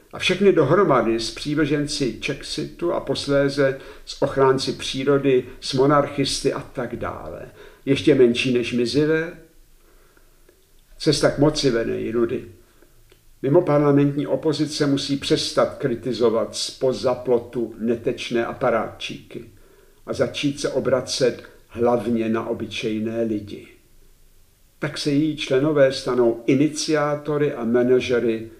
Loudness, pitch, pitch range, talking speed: -21 LUFS, 135 Hz, 120-145 Hz, 105 wpm